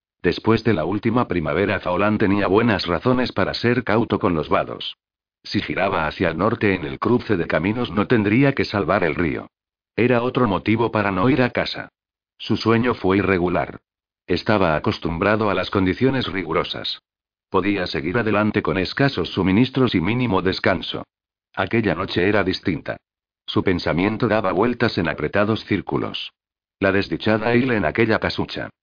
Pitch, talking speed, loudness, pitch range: 105 Hz, 155 wpm, -20 LUFS, 95-115 Hz